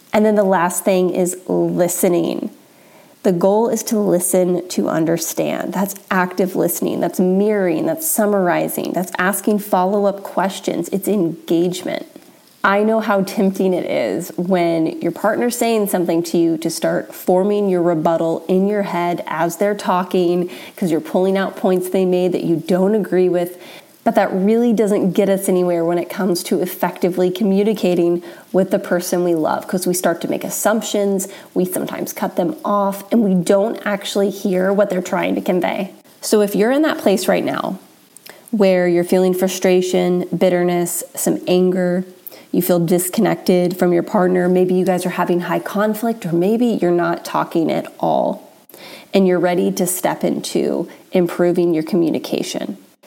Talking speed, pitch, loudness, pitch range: 165 wpm, 185 Hz, -17 LUFS, 180-200 Hz